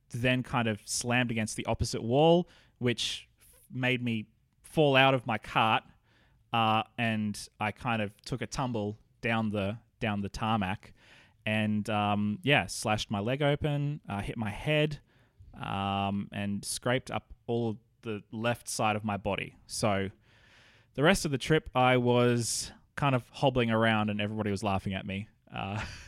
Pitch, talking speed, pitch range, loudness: 115 Hz, 165 wpm, 105-125 Hz, -30 LUFS